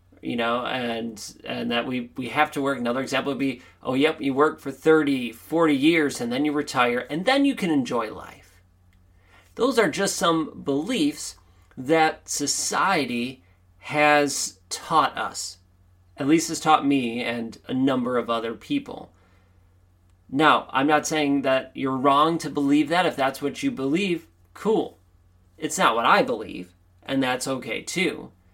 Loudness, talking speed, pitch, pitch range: -23 LUFS, 165 wpm, 130 Hz, 95-150 Hz